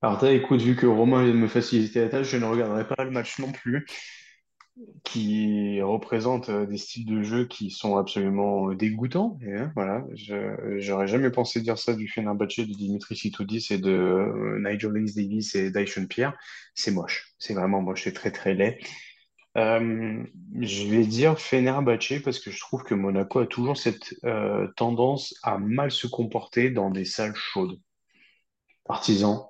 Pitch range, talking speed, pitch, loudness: 100-125 Hz, 175 wpm, 115 Hz, -26 LUFS